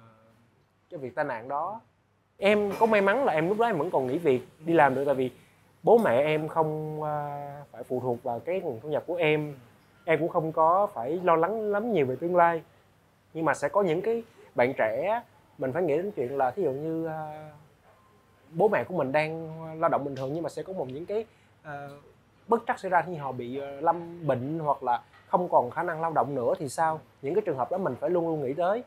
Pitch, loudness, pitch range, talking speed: 155 Hz, -27 LUFS, 135-170 Hz, 235 wpm